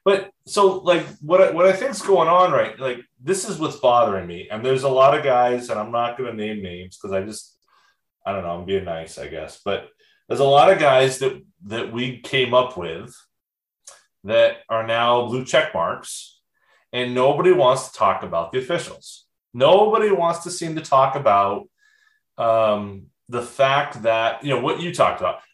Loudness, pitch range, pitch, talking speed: -19 LUFS, 115-185 Hz, 130 Hz, 195 wpm